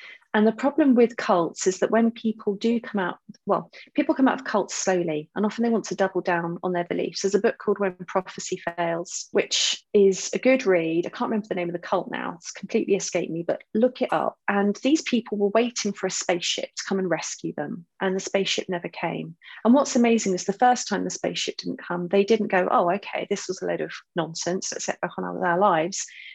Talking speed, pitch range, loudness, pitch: 240 wpm, 180-225 Hz, -24 LUFS, 200 Hz